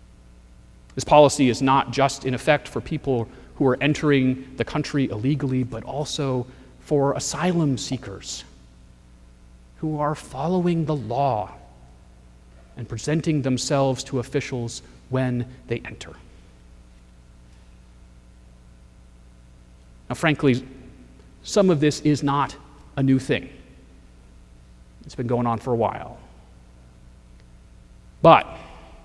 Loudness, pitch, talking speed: -22 LUFS, 115 Hz, 105 wpm